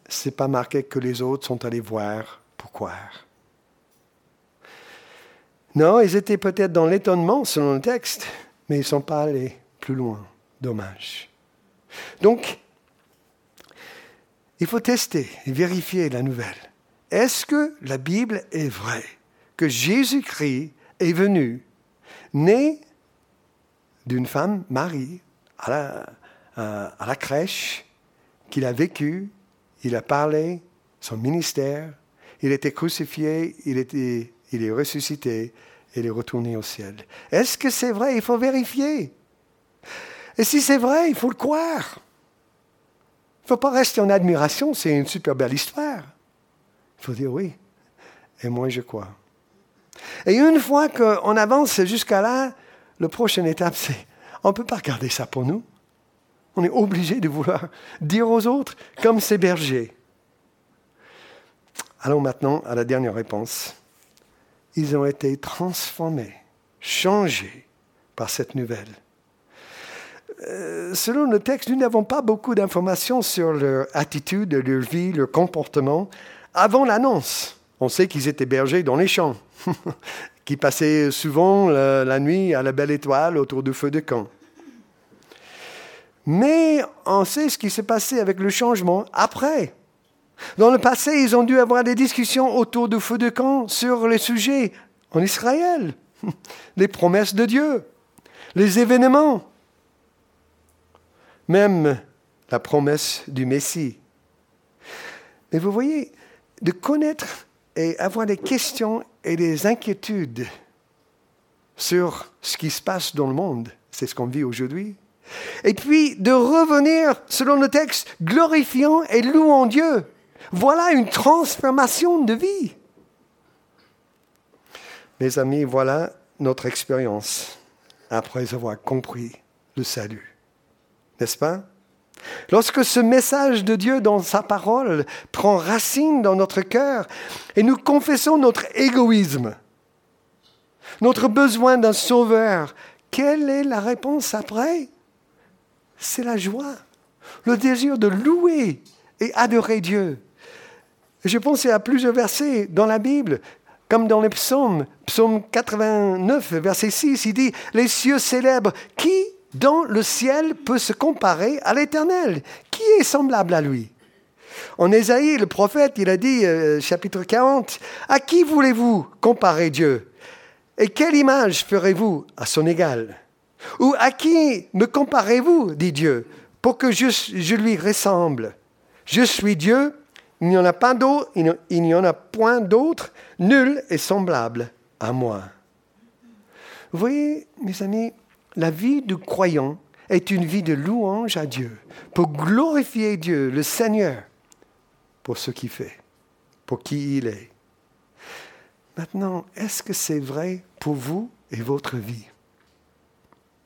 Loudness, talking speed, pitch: -20 LUFS, 135 wpm, 195 Hz